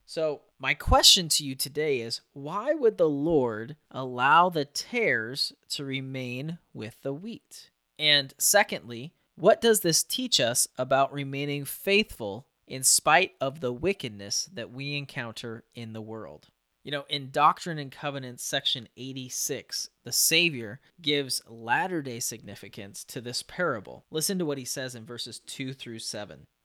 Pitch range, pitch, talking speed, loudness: 120-155 Hz, 140 Hz, 150 wpm, -26 LUFS